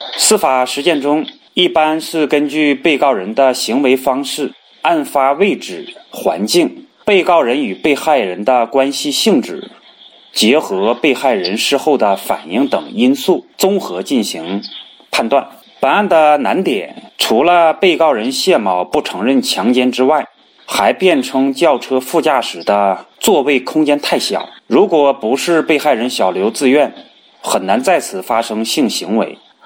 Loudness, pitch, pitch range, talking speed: -14 LUFS, 150 Hz, 130-175 Hz, 220 characters per minute